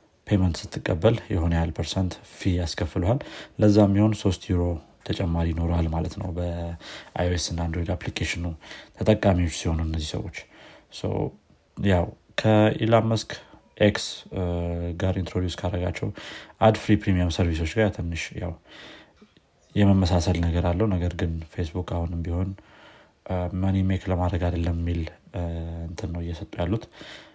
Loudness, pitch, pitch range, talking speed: -25 LUFS, 90 Hz, 85-100 Hz, 120 wpm